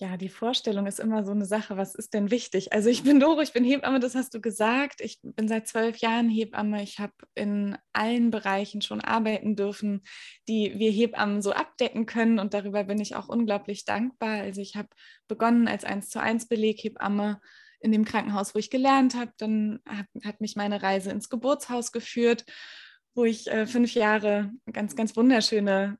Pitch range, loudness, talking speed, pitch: 205-235 Hz, -26 LUFS, 195 wpm, 220 Hz